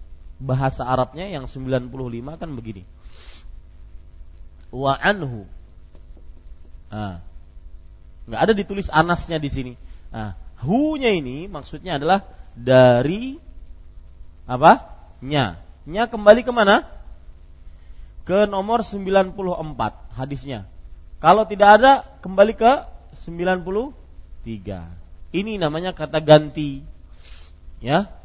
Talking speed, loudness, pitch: 85 wpm, -19 LUFS, 125 Hz